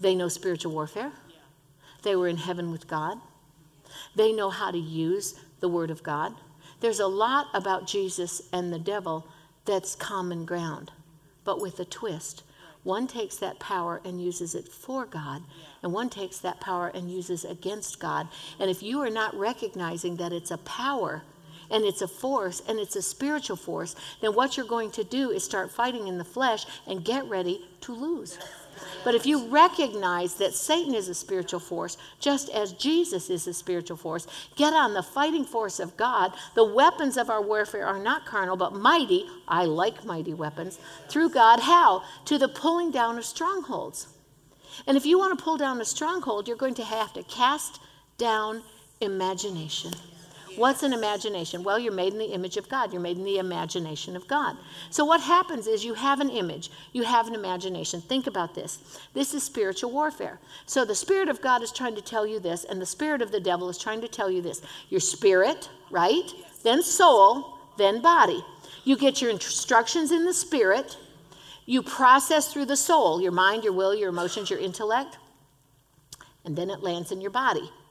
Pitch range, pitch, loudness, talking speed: 175-260 Hz, 200 Hz, -26 LUFS, 190 wpm